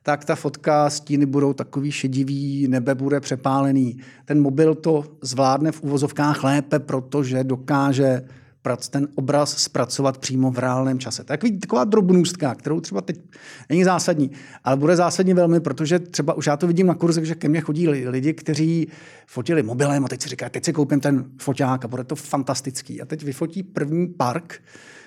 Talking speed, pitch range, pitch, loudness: 170 wpm, 135-160 Hz, 145 Hz, -21 LUFS